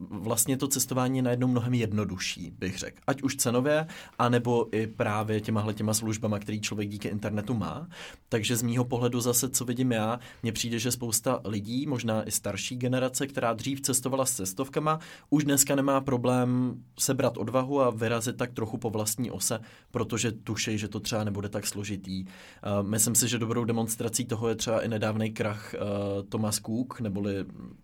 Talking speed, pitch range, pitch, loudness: 170 wpm, 105-125 Hz, 115 Hz, -29 LUFS